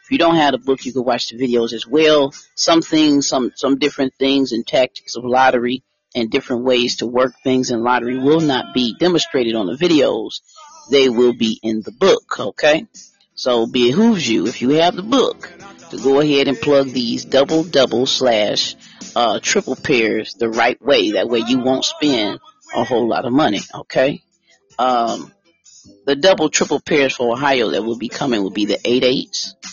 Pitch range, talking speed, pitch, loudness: 125-160 Hz, 190 wpm, 135 Hz, -16 LUFS